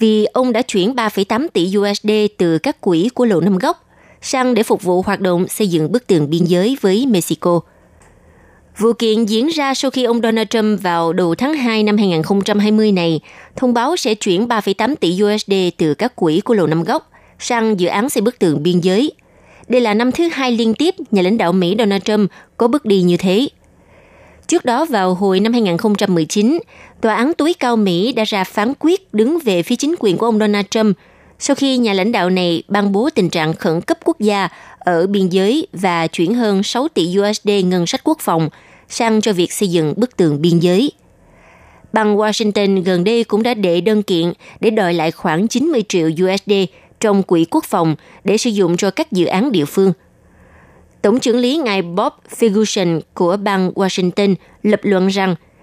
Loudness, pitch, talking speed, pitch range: -15 LUFS, 205 Hz, 200 wpm, 180-235 Hz